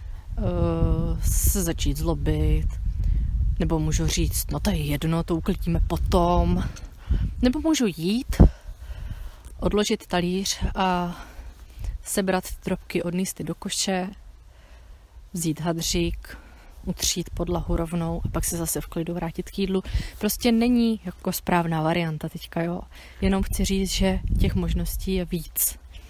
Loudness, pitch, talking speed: -25 LUFS, 170 Hz, 130 wpm